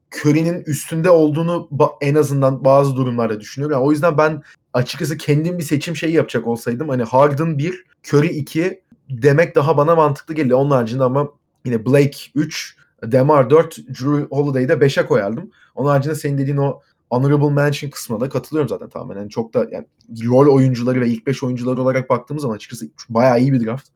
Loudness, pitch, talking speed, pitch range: -17 LUFS, 145 Hz, 180 wpm, 130-155 Hz